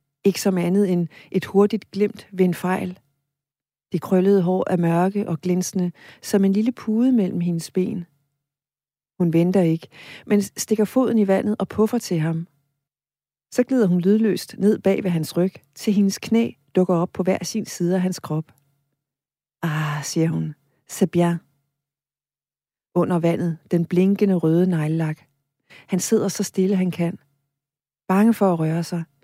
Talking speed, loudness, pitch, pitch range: 155 wpm, -21 LUFS, 175 Hz, 150-195 Hz